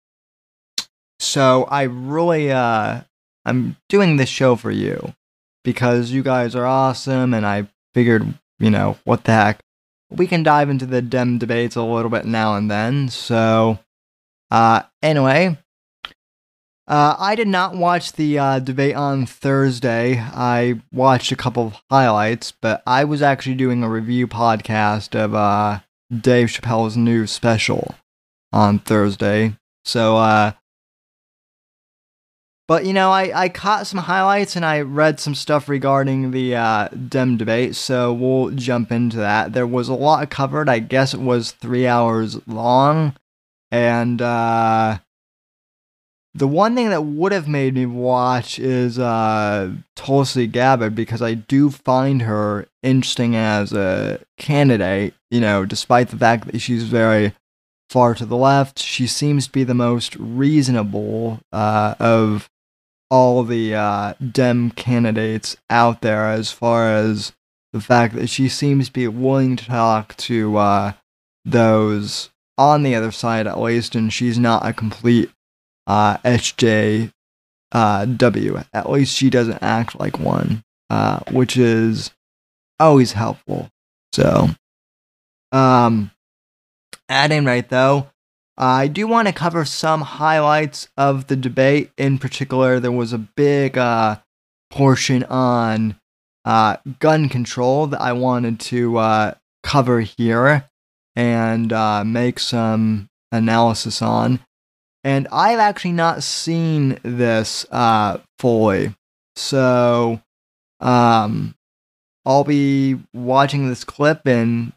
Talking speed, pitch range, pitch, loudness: 135 wpm, 110-135 Hz, 120 Hz, -17 LUFS